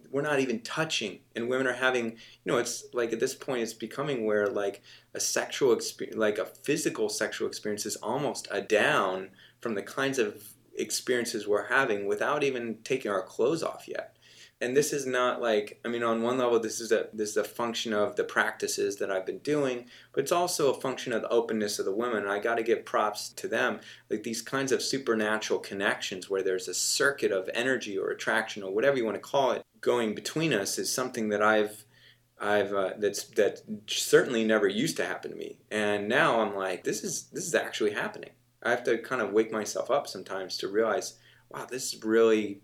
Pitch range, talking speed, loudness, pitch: 110-140 Hz, 215 wpm, -29 LUFS, 120 Hz